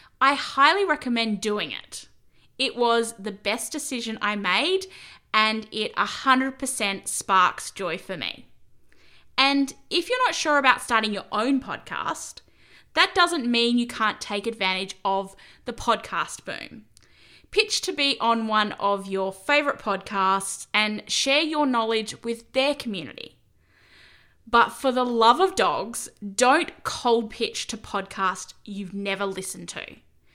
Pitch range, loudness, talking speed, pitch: 205-275 Hz, -24 LUFS, 140 wpm, 230 Hz